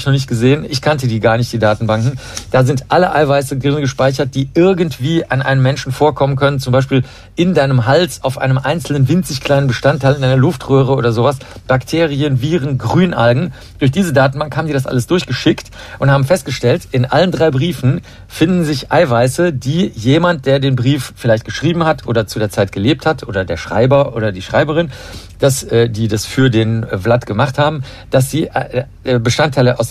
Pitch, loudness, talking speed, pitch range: 135 Hz, -14 LUFS, 185 wpm, 120-150 Hz